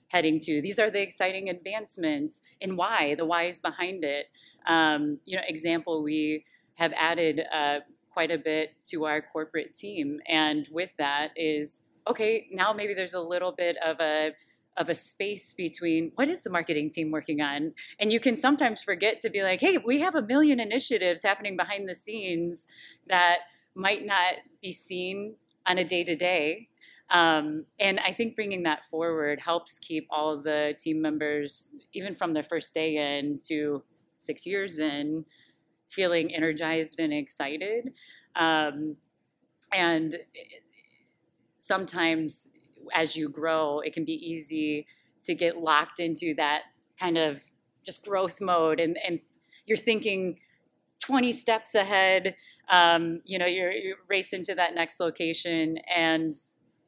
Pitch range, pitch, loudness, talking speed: 155-195 Hz, 170 Hz, -27 LUFS, 155 wpm